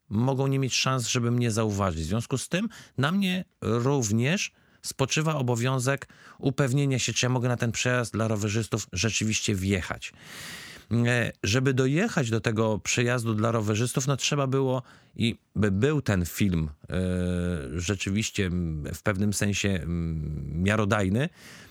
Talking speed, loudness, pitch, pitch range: 135 wpm, -27 LUFS, 115 Hz, 100-130 Hz